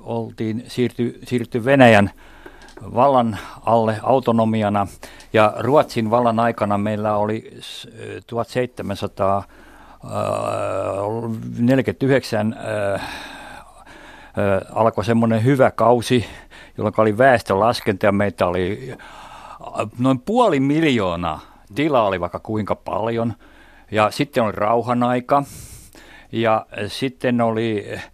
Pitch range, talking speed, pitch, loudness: 105-125 Hz, 85 wpm, 115 Hz, -19 LUFS